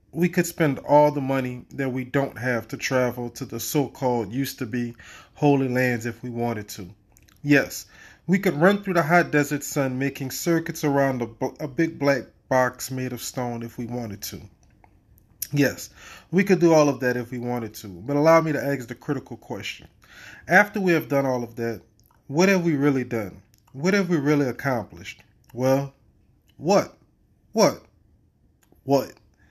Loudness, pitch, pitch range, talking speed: -23 LUFS, 130 Hz, 115-145 Hz, 180 wpm